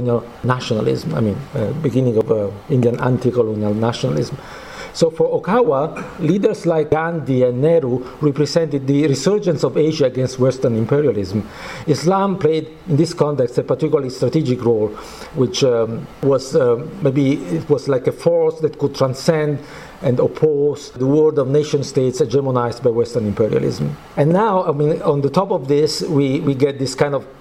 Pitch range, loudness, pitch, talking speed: 125-155 Hz, -18 LUFS, 140 Hz, 160 wpm